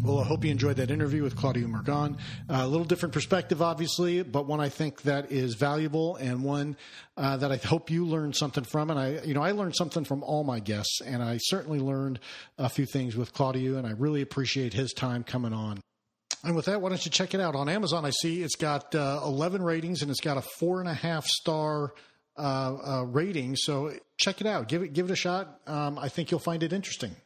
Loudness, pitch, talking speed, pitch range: -29 LUFS, 145 Hz, 240 wpm, 135-165 Hz